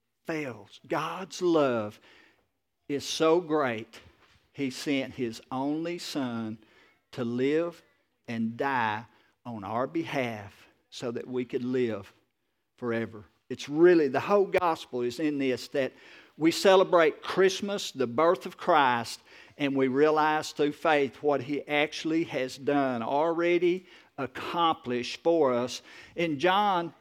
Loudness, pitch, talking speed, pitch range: -28 LUFS, 140 Hz, 125 wpm, 125-165 Hz